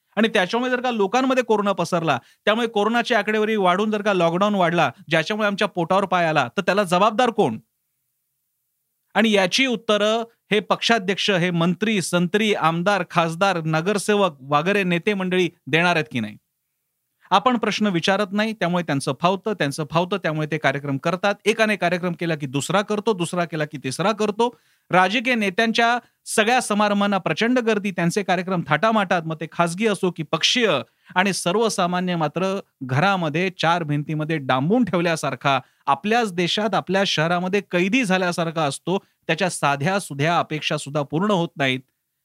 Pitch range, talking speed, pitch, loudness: 160-210 Hz, 150 wpm, 185 Hz, -21 LUFS